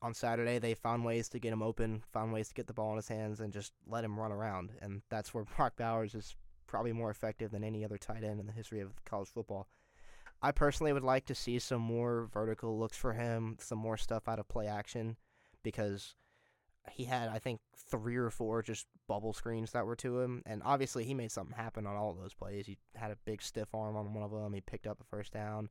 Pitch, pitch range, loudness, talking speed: 110 Hz, 105-115 Hz, -39 LUFS, 245 wpm